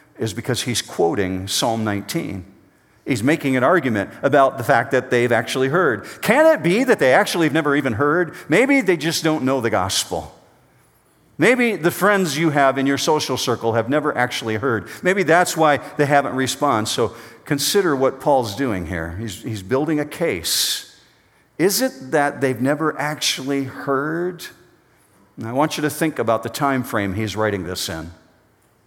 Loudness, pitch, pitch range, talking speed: -19 LUFS, 135 Hz, 115-155 Hz, 175 wpm